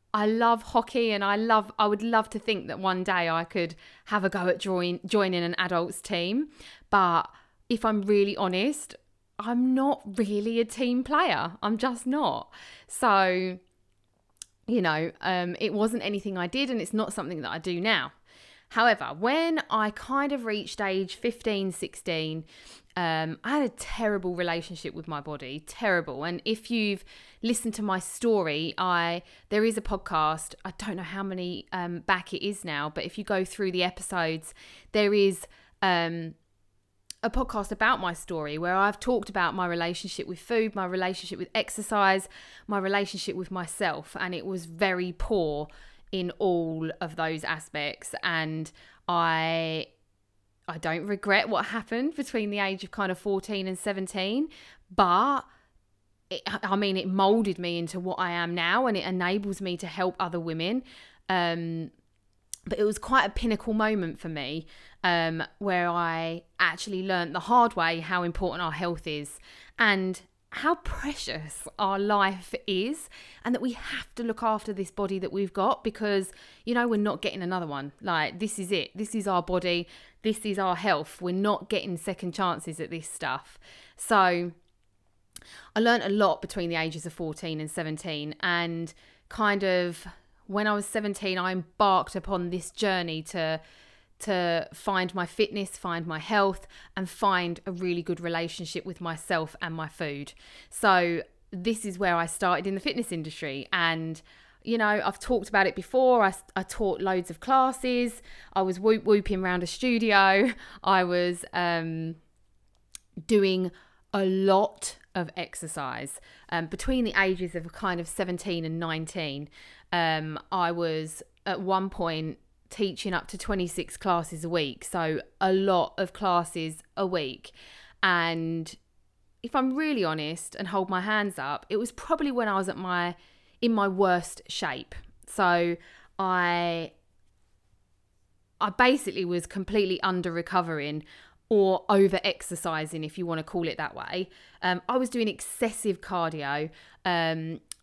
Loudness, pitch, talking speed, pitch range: -28 LUFS, 185 Hz, 165 wpm, 170-205 Hz